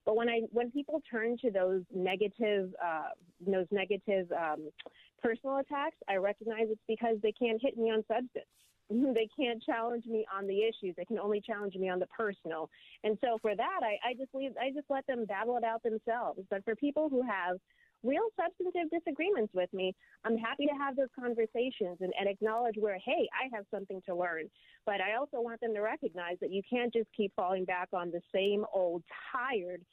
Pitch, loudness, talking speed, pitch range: 220 Hz, -35 LUFS, 205 wpm, 195-245 Hz